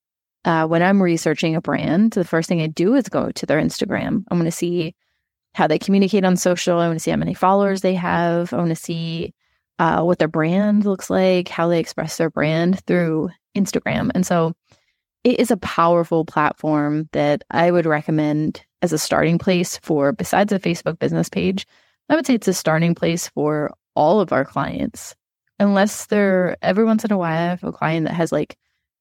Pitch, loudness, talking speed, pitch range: 170 Hz, -19 LUFS, 205 wpm, 160-190 Hz